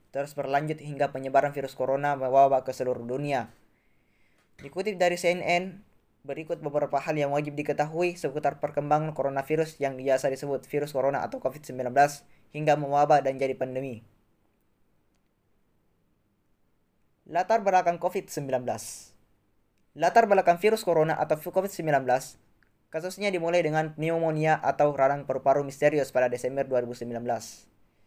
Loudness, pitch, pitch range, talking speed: -27 LUFS, 140 Hz, 130-155 Hz, 115 wpm